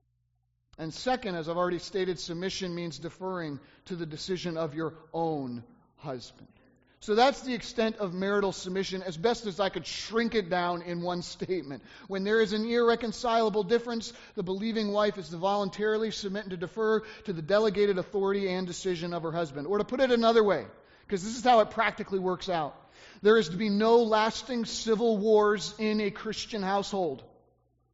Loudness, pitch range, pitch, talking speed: -29 LUFS, 175-220 Hz, 195 Hz, 185 wpm